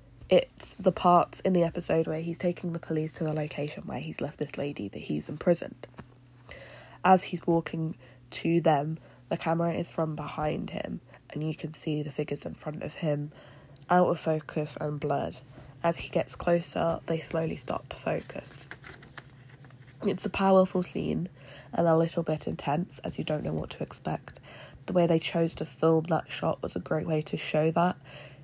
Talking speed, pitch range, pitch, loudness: 185 wpm, 145-170 Hz, 160 Hz, -29 LUFS